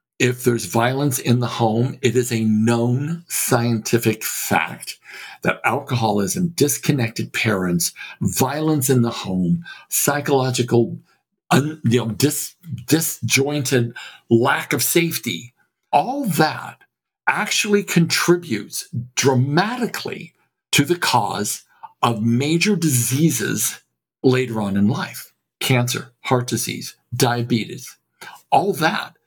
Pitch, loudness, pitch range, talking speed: 130 Hz, -20 LUFS, 115-150 Hz, 105 wpm